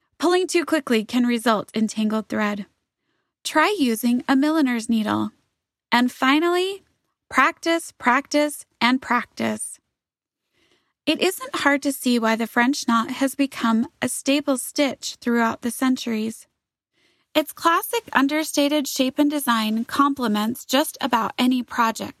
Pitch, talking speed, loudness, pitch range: 255 Hz, 125 wpm, -21 LUFS, 230-295 Hz